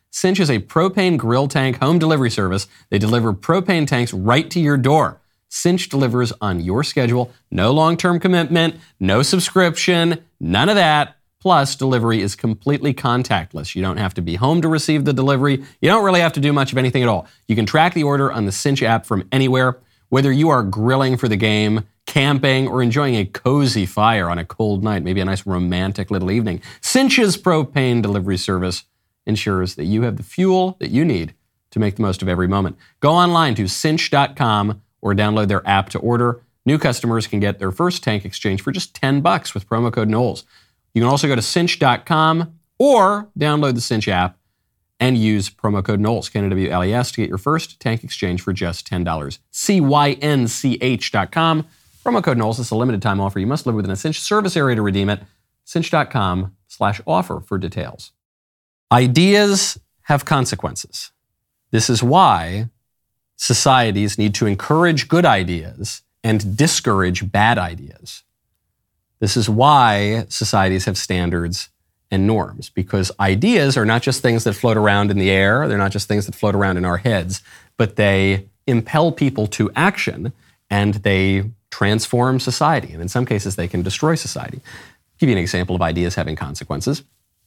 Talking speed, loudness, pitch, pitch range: 180 wpm, -18 LUFS, 115 Hz, 100-145 Hz